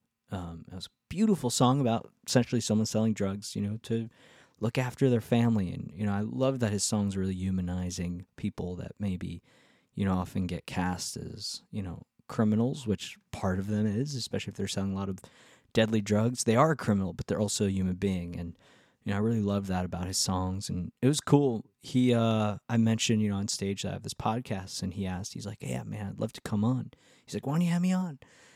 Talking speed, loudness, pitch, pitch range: 235 wpm, -30 LUFS, 105 Hz, 95-120 Hz